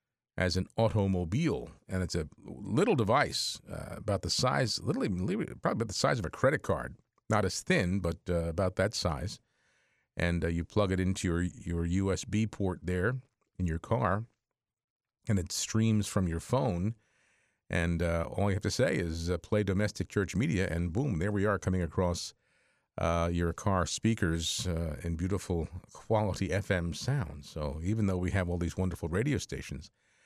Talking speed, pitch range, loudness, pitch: 175 wpm, 85-105 Hz, -32 LUFS, 95 Hz